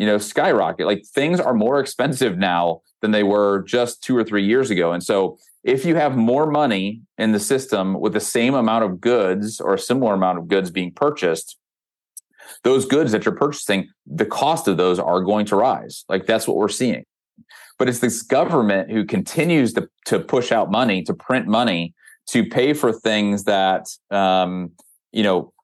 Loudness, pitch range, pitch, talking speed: -19 LUFS, 95-120 Hz, 105 Hz, 190 wpm